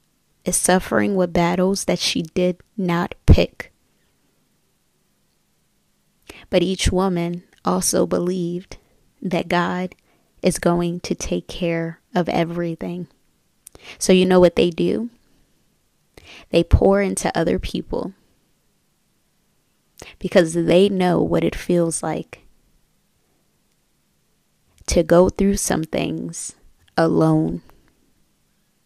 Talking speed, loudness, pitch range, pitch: 100 wpm, -20 LUFS, 170-185 Hz, 175 Hz